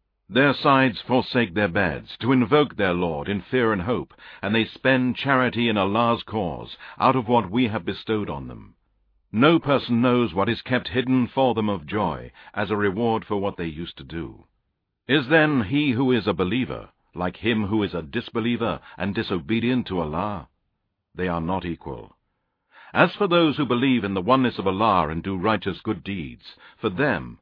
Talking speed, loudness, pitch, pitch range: 190 wpm, -23 LUFS, 110 Hz, 95-125 Hz